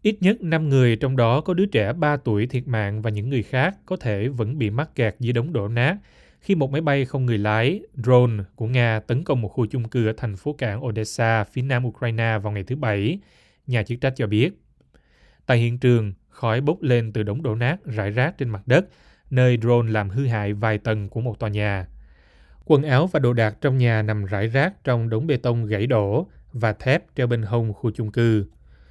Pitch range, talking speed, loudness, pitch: 110-130 Hz, 230 wpm, -22 LUFS, 120 Hz